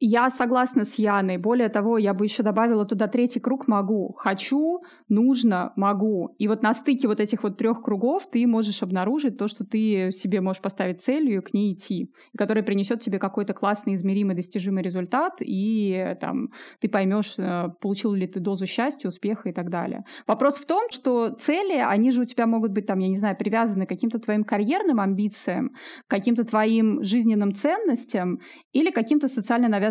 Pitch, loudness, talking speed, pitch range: 220 Hz, -24 LUFS, 185 wpm, 200-245 Hz